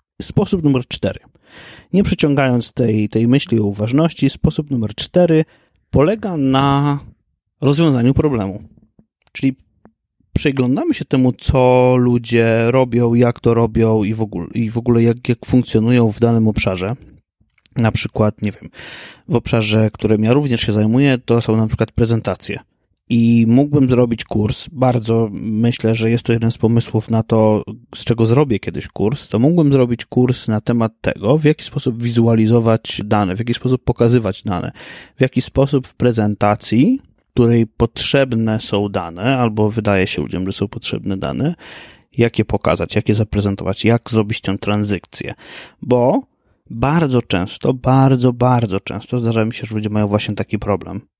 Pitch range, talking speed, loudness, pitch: 110-130 Hz, 155 wpm, -16 LUFS, 115 Hz